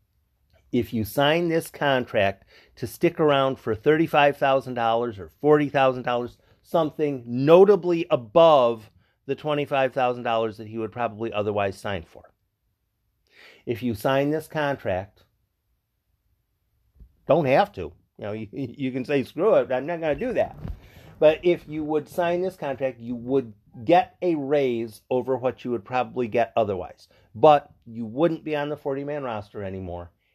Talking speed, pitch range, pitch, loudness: 150 wpm, 105-145 Hz, 125 Hz, -23 LUFS